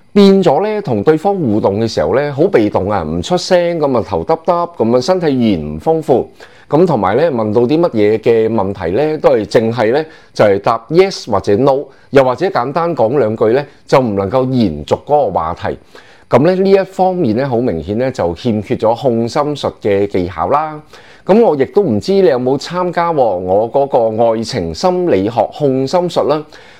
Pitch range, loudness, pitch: 115-175 Hz, -13 LUFS, 135 Hz